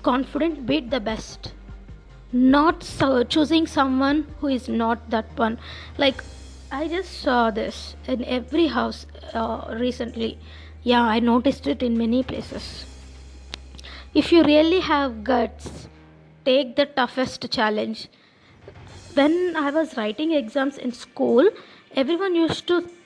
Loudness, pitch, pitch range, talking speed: -22 LUFS, 260 Hz, 230-300 Hz, 125 wpm